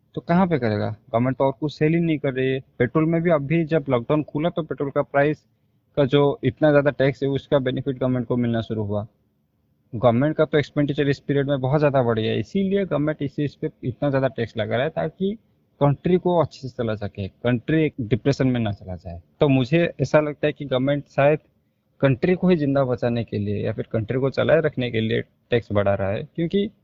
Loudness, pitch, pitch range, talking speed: -22 LUFS, 140 Hz, 120-150 Hz, 230 wpm